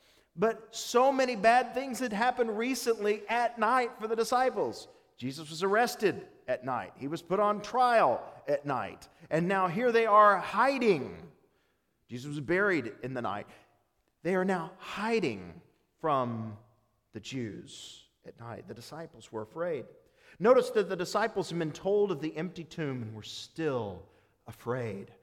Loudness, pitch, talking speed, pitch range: -30 LUFS, 195 Hz, 155 wpm, 145-240 Hz